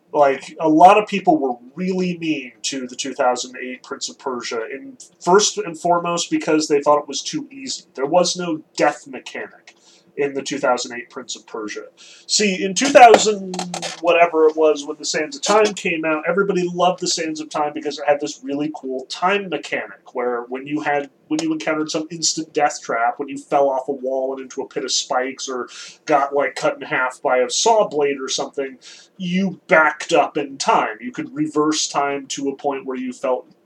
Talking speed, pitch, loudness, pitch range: 205 wpm, 155 Hz, -19 LUFS, 140-180 Hz